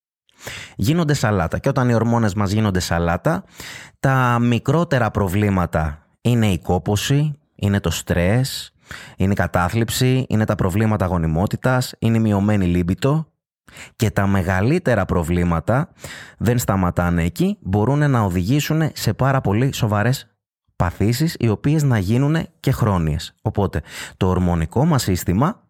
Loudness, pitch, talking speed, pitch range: -19 LUFS, 110 Hz, 130 wpm, 95-130 Hz